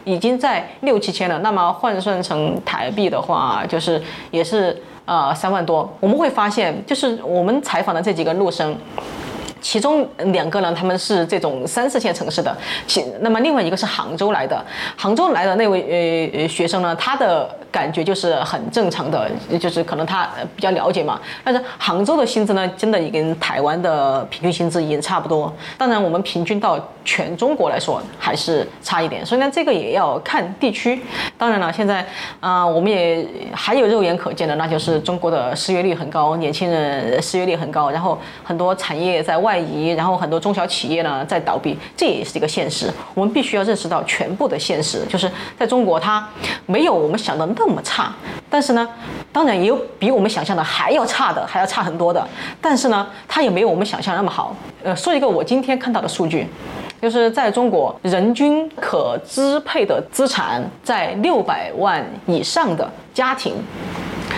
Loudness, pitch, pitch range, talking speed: -19 LUFS, 185 Hz, 170-235 Hz, 290 characters per minute